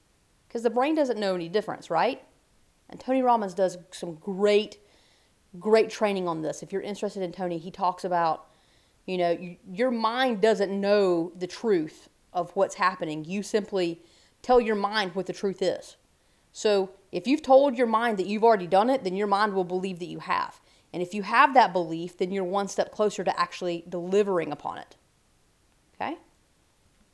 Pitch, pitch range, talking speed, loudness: 195 Hz, 180-220 Hz, 185 wpm, -26 LUFS